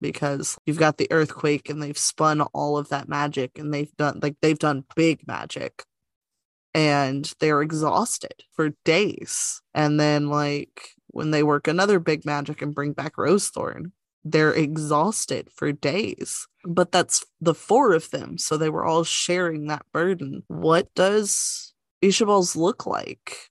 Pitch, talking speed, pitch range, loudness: 155 Hz, 160 wpm, 145-165 Hz, -23 LUFS